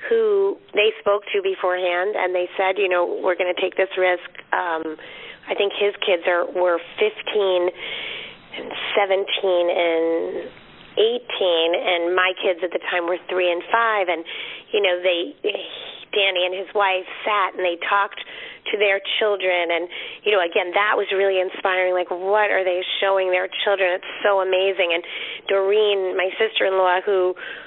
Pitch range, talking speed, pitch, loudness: 180-215 Hz, 165 wpm, 190 Hz, -21 LUFS